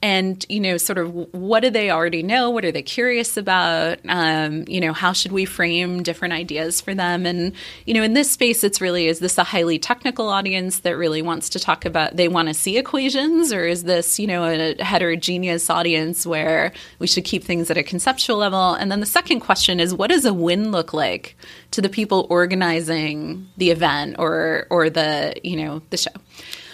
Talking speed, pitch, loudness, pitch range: 210 wpm, 180 Hz, -19 LUFS, 170-200 Hz